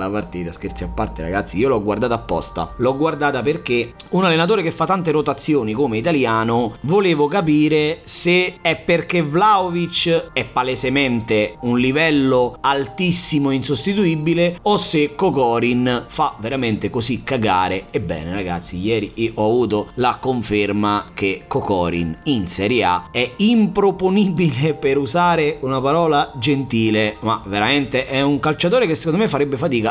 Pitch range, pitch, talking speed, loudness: 110-165 Hz, 135 Hz, 140 wpm, -18 LUFS